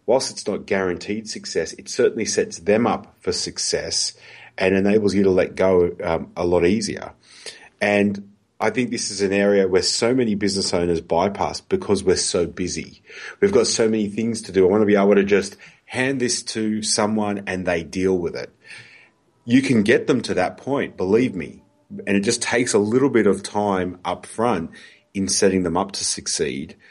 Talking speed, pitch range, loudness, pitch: 195 wpm, 95-110 Hz, -20 LUFS, 100 Hz